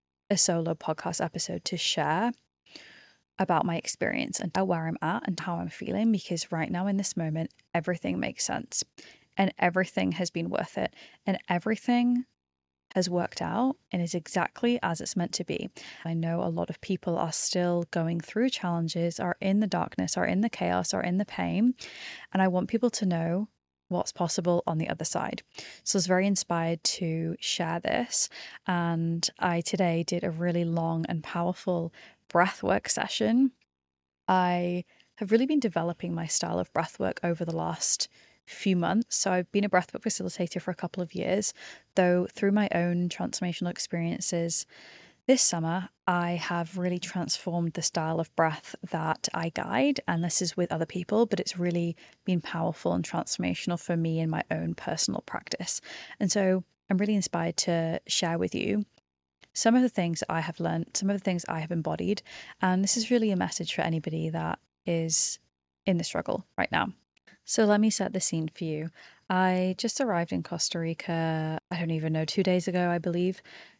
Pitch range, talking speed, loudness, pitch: 165-190 Hz, 180 wpm, -29 LUFS, 175 Hz